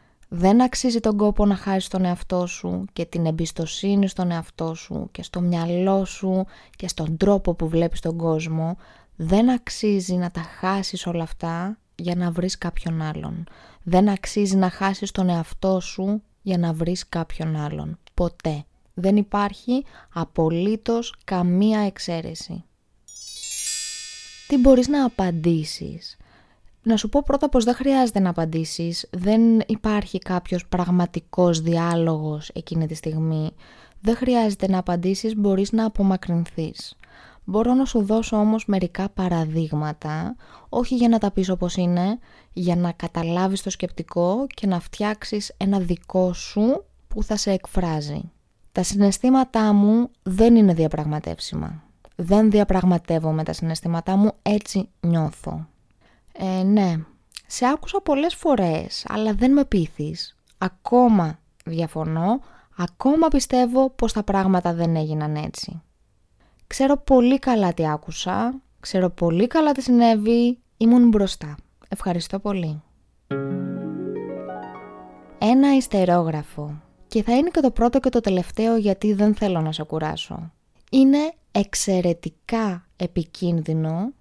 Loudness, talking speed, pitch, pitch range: -22 LUFS, 130 wpm, 185 Hz, 170-220 Hz